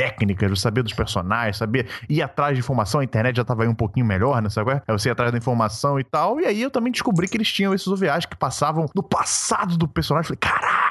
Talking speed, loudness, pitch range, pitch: 260 wpm, -21 LUFS, 115-170 Hz, 135 Hz